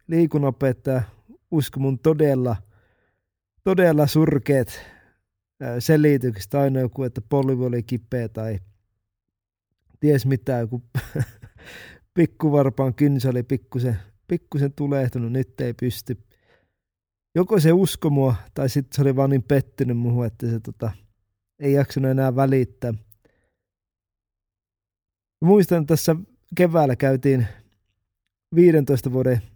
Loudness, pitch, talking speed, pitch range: -21 LUFS, 125 Hz, 105 wpm, 105-140 Hz